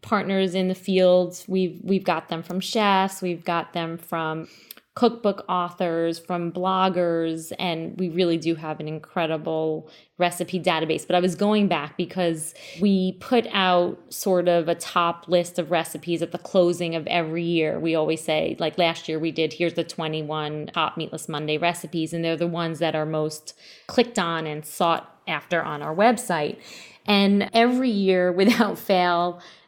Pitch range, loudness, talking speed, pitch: 165-185 Hz, -24 LUFS, 170 wpm, 175 Hz